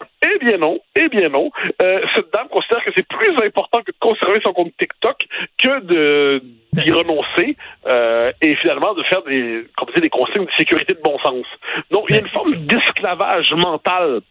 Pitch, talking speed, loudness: 195 Hz, 195 wpm, -16 LUFS